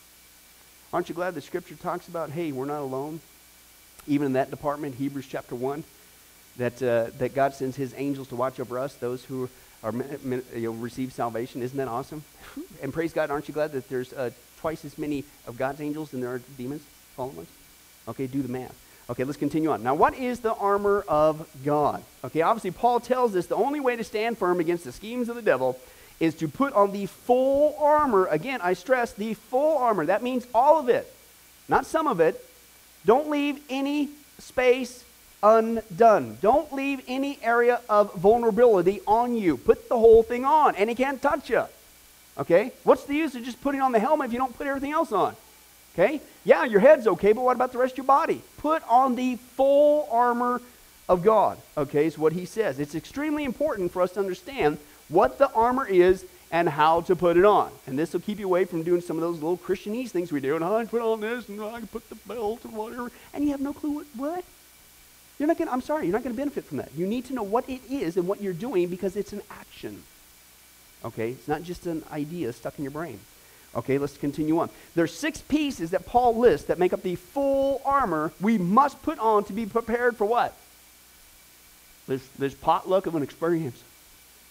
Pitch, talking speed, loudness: 185 Hz, 215 wpm, -25 LUFS